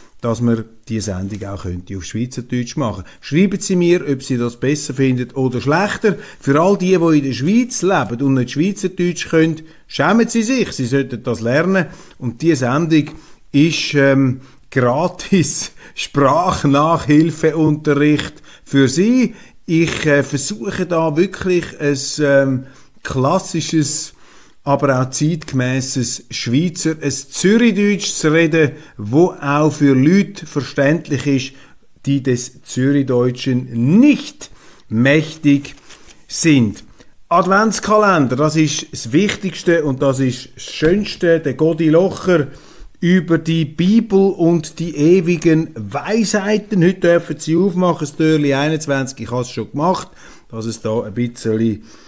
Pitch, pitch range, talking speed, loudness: 150 Hz, 130-175 Hz, 130 wpm, -16 LUFS